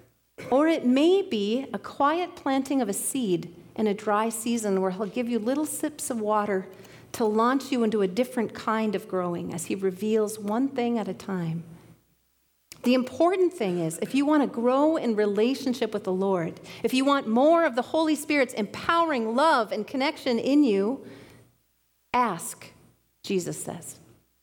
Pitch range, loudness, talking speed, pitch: 200-270 Hz, -26 LUFS, 170 wpm, 230 Hz